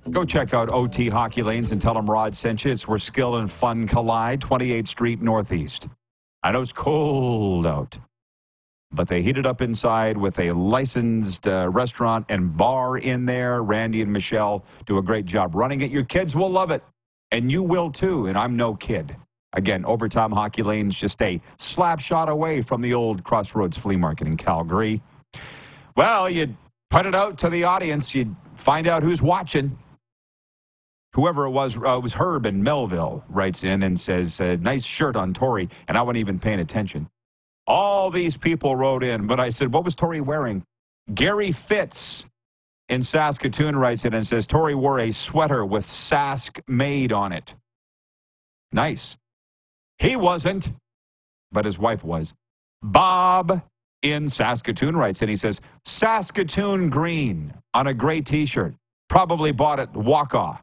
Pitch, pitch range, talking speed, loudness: 125 Hz, 105-145 Hz, 170 wpm, -22 LUFS